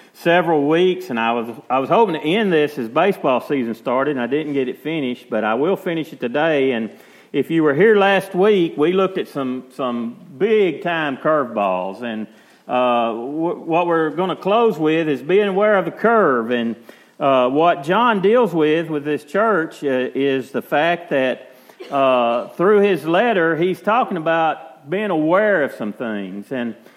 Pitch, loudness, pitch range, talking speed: 155 Hz, -18 LUFS, 125-185 Hz, 190 wpm